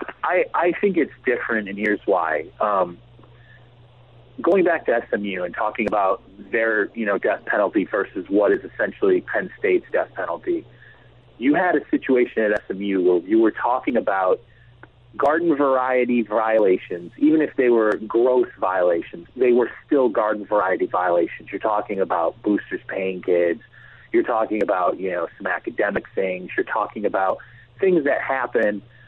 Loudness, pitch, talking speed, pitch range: -21 LUFS, 120 Hz, 155 wpm, 105-135 Hz